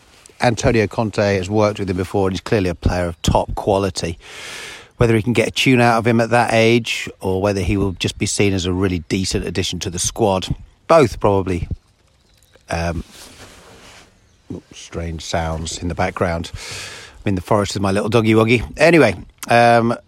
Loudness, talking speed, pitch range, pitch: -17 LUFS, 180 wpm, 90-110 Hz, 100 Hz